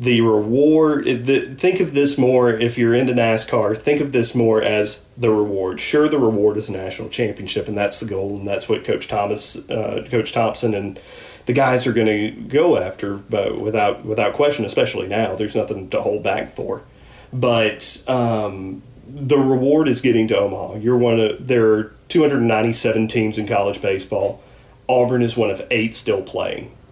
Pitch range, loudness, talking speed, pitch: 105-125 Hz, -19 LUFS, 185 wpm, 115 Hz